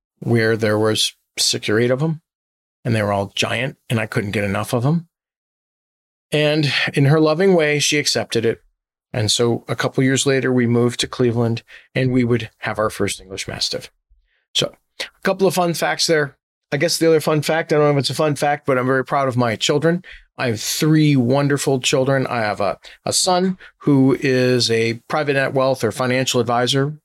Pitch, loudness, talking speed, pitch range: 130 Hz, -18 LUFS, 210 wpm, 115-150 Hz